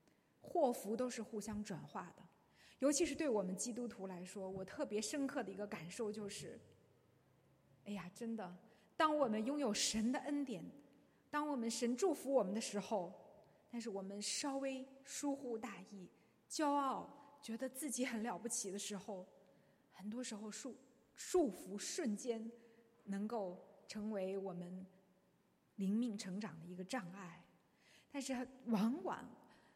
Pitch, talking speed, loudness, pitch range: 225 Hz, 215 characters per minute, -43 LUFS, 200-260 Hz